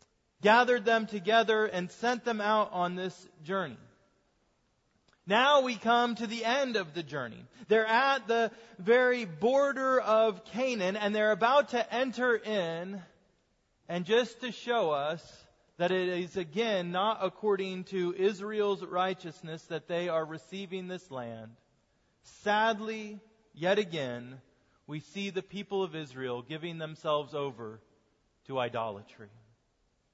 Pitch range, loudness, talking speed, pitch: 155-220 Hz, -30 LUFS, 130 wpm, 190 Hz